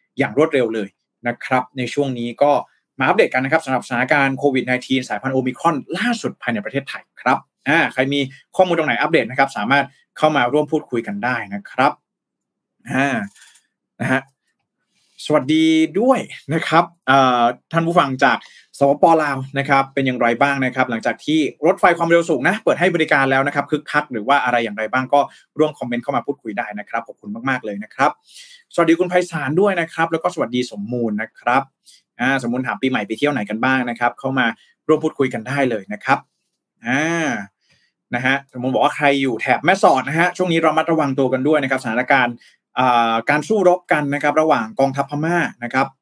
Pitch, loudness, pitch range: 140 Hz, -18 LUFS, 125-160 Hz